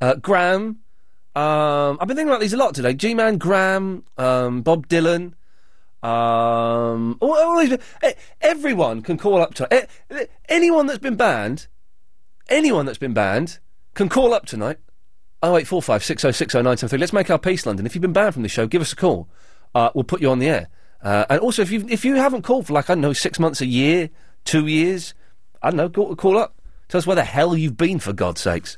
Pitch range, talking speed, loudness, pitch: 130-210 Hz, 215 wpm, -19 LUFS, 170 Hz